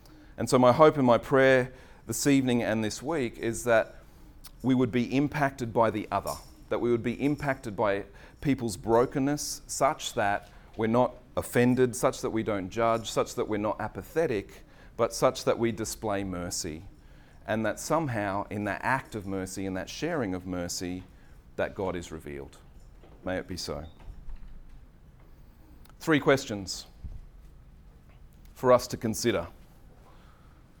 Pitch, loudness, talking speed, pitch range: 110 Hz, -28 LUFS, 150 wpm, 90-125 Hz